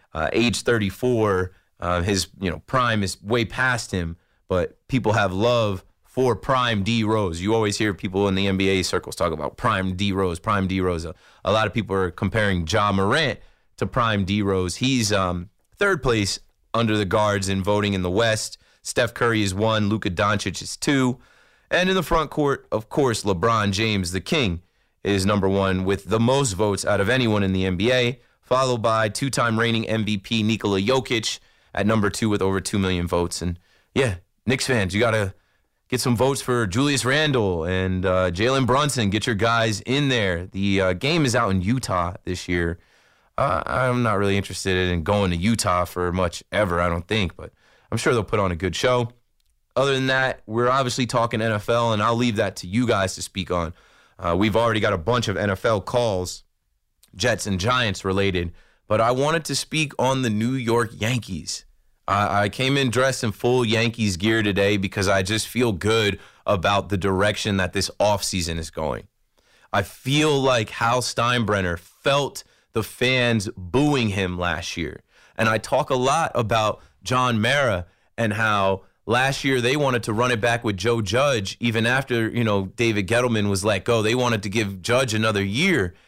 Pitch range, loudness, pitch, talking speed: 95-120 Hz, -22 LUFS, 105 Hz, 190 wpm